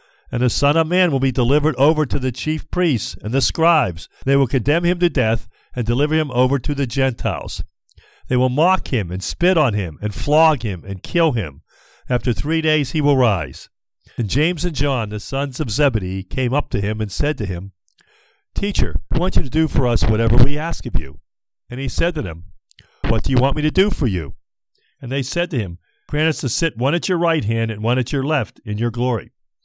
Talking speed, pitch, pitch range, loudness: 230 wpm, 130 Hz, 105-150 Hz, -19 LUFS